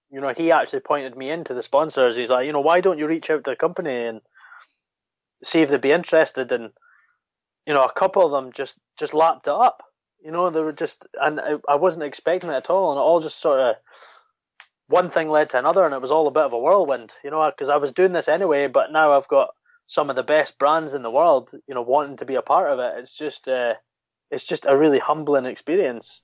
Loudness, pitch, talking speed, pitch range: -20 LUFS, 155 Hz, 250 wpm, 140-165 Hz